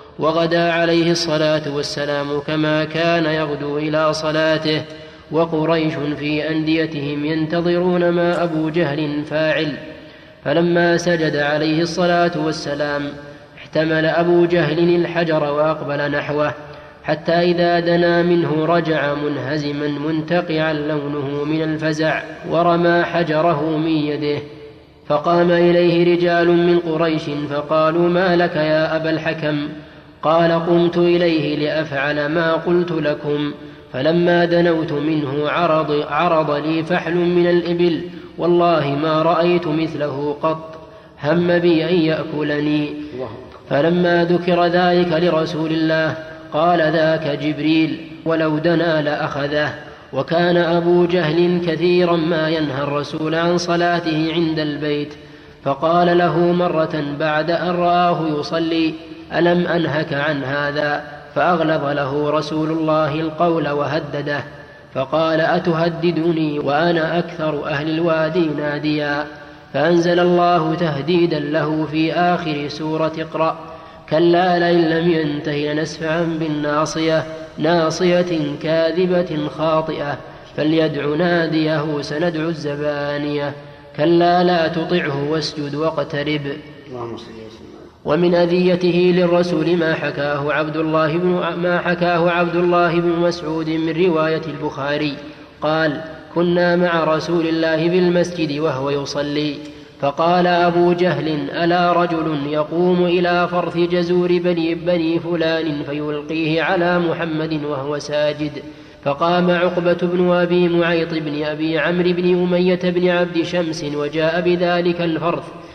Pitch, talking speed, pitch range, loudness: 160 Hz, 110 wpm, 150-170 Hz, -18 LUFS